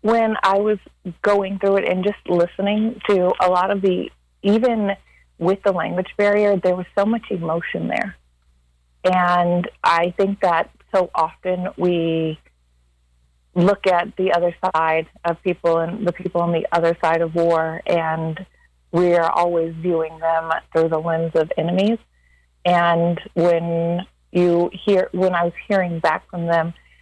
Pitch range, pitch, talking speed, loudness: 165-190 Hz, 175 Hz, 155 wpm, -20 LUFS